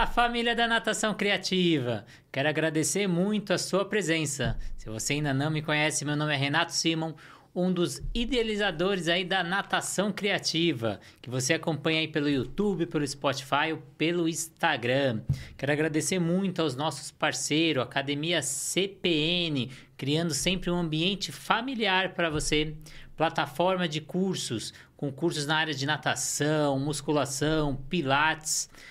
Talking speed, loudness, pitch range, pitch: 135 wpm, -28 LUFS, 145-180 Hz, 160 Hz